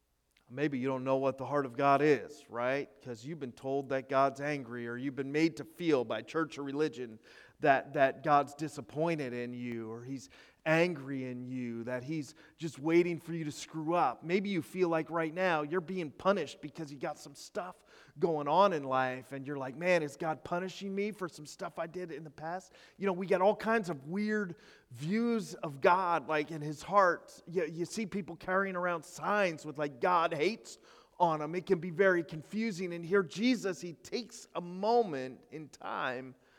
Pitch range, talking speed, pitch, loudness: 135-180 Hz, 205 wpm, 155 Hz, -33 LUFS